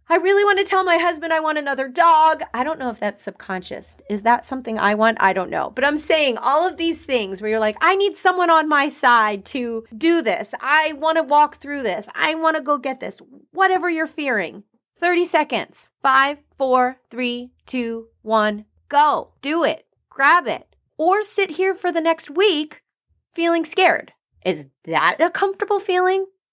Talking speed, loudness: 190 wpm, -19 LUFS